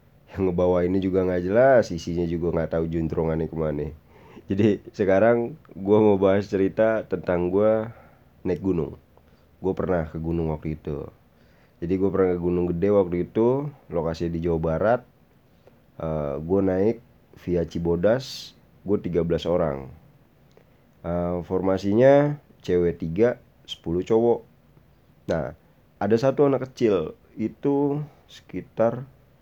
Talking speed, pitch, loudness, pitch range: 125 wpm, 95 Hz, -24 LUFS, 85-115 Hz